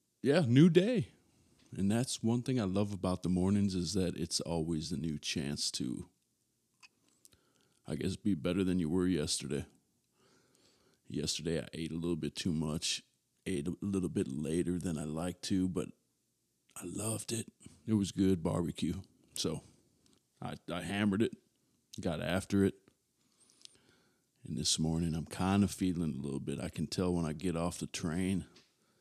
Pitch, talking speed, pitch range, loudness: 90 Hz, 165 wpm, 80-100 Hz, -34 LUFS